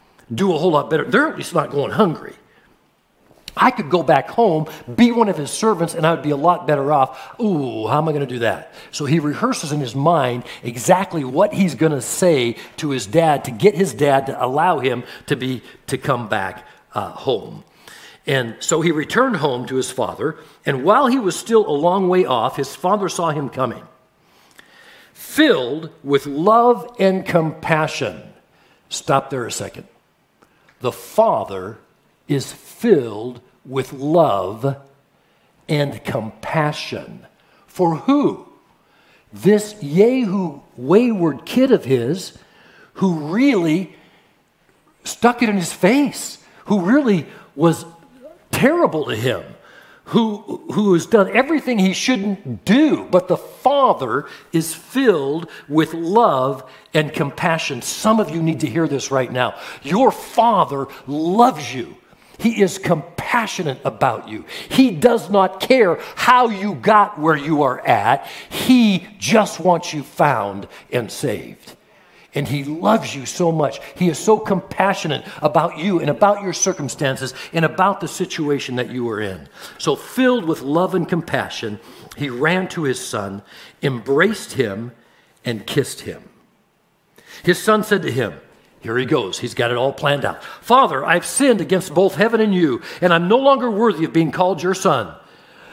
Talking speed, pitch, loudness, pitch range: 155 wpm, 165 Hz, -18 LUFS, 140-200 Hz